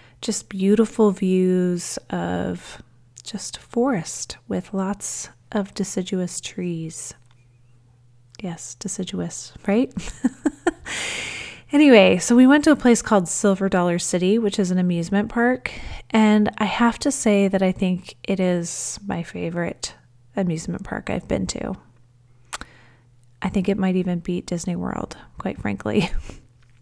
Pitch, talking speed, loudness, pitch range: 185 Hz, 130 wpm, -22 LUFS, 125-210 Hz